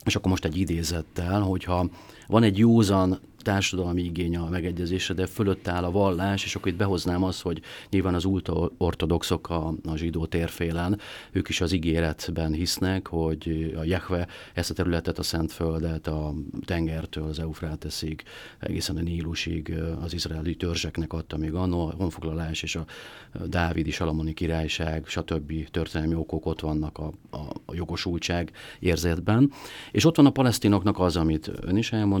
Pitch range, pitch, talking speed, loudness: 80-95 Hz, 85 Hz, 165 wpm, -27 LUFS